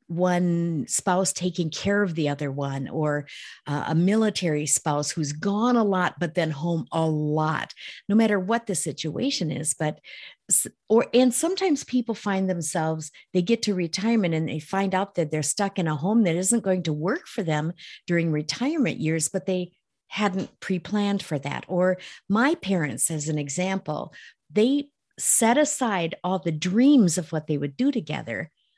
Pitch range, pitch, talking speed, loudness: 155-205 Hz, 180 Hz, 175 wpm, -24 LUFS